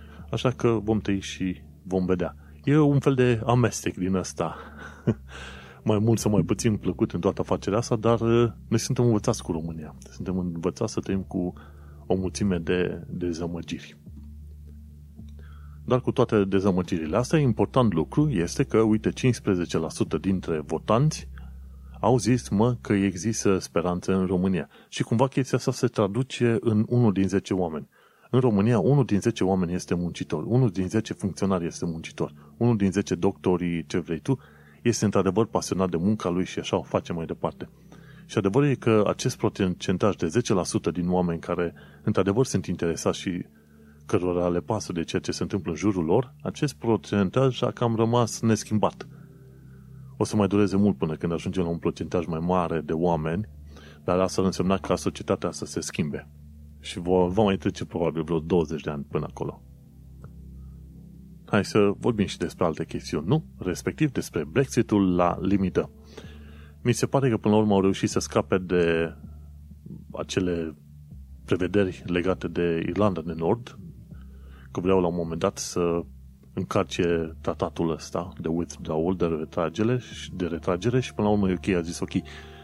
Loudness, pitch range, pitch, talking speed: -26 LUFS, 80-110 Hz, 95 Hz, 165 wpm